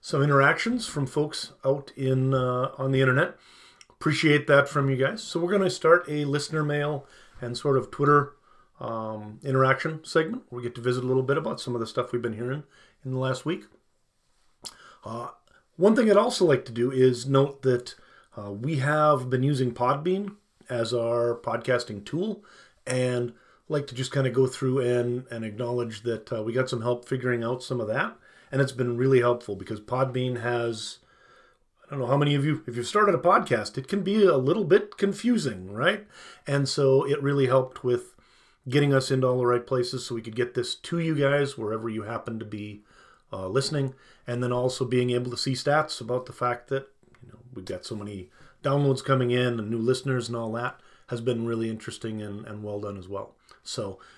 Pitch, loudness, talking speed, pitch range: 130 Hz, -26 LUFS, 205 wpm, 120-145 Hz